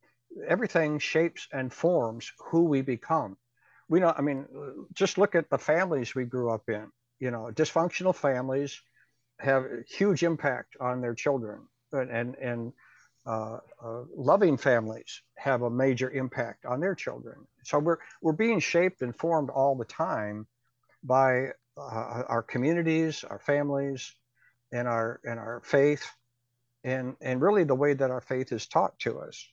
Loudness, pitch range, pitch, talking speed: -29 LUFS, 120-155 Hz, 130 Hz, 155 wpm